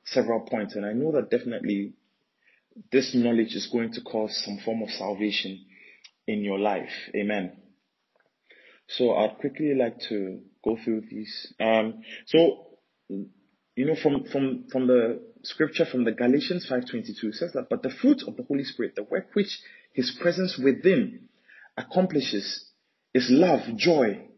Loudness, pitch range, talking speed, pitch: -26 LUFS, 110-155 Hz, 155 wpm, 125 Hz